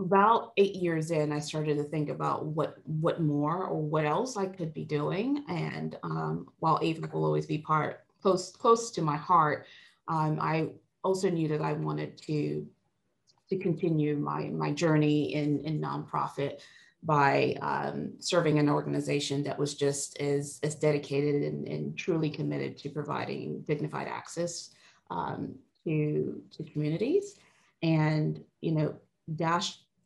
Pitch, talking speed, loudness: 150 Hz, 150 wpm, -30 LUFS